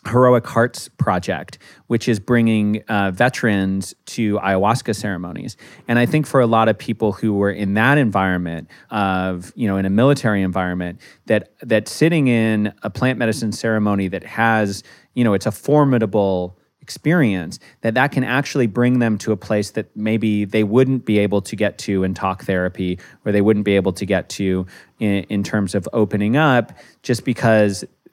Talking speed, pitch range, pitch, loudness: 180 wpm, 100-120 Hz, 105 Hz, -18 LUFS